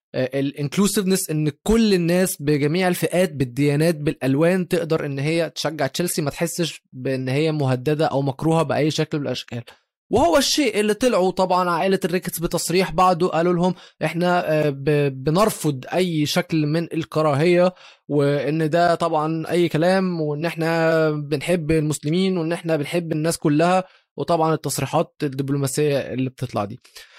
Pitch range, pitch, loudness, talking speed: 150-180 Hz, 160 Hz, -21 LUFS, 135 wpm